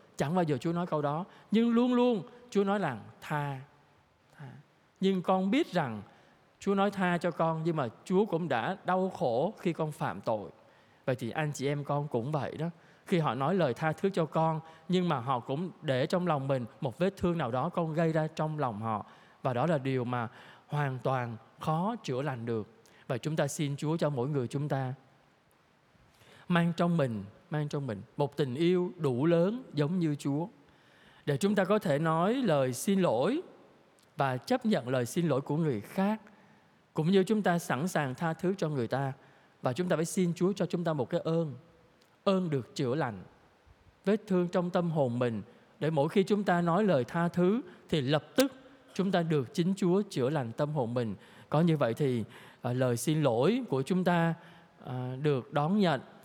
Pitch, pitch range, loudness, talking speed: 160 Hz, 135-180 Hz, -31 LUFS, 205 wpm